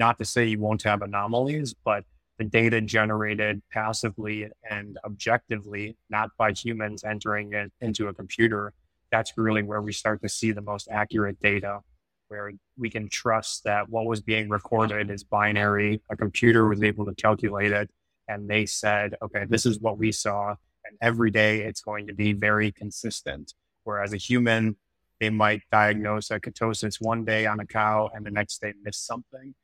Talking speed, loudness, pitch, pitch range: 180 wpm, -26 LUFS, 105 Hz, 105-110 Hz